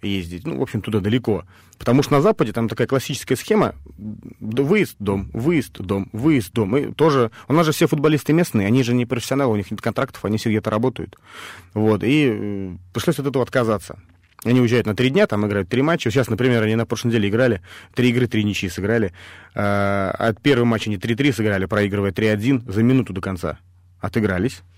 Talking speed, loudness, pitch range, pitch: 195 wpm, -20 LUFS, 100-130 Hz, 110 Hz